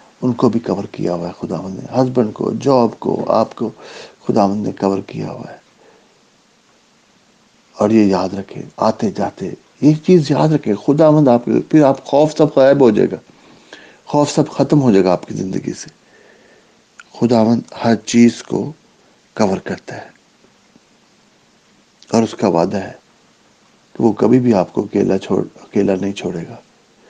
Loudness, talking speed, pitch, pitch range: -15 LUFS, 180 wpm, 120 Hz, 105-145 Hz